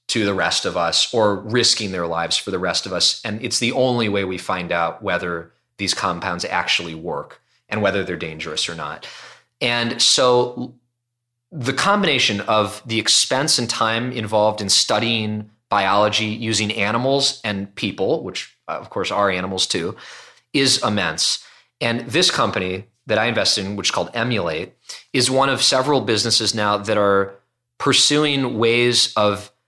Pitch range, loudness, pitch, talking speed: 100-120 Hz, -19 LUFS, 110 Hz, 160 wpm